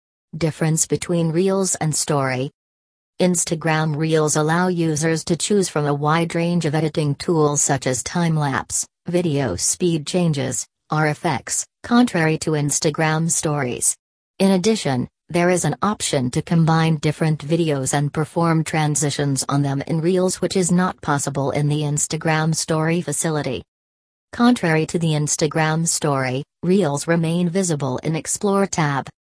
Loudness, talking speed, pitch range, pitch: -20 LUFS, 135 wpm, 145-170 Hz, 155 Hz